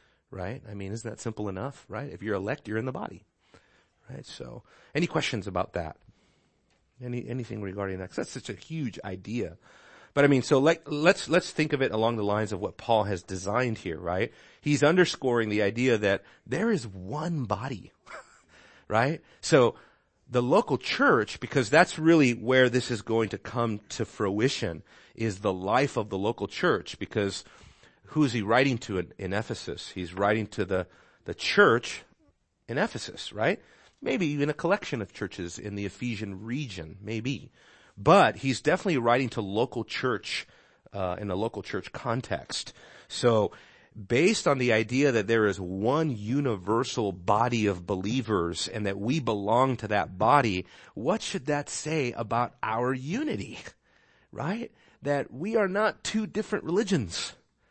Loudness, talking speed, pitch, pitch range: -28 LUFS, 170 wpm, 115 Hz, 105-140 Hz